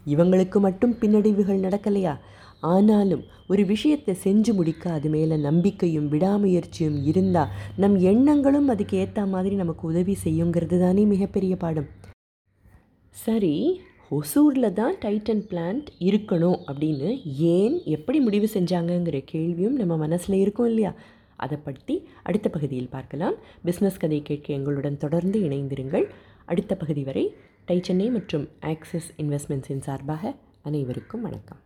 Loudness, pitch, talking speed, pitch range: -24 LUFS, 180 Hz, 120 wpm, 150-205 Hz